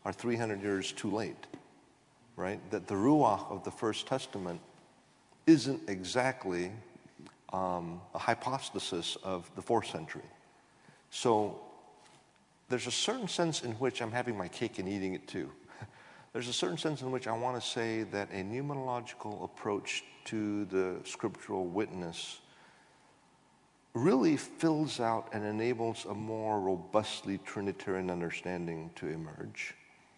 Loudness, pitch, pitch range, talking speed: -35 LUFS, 110 Hz, 95-125 Hz, 135 wpm